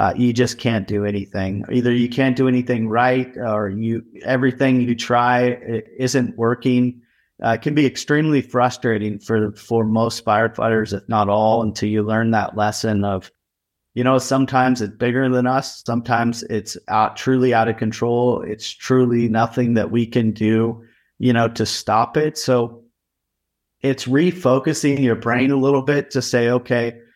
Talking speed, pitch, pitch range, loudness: 170 wpm, 120 Hz, 110-130 Hz, -19 LUFS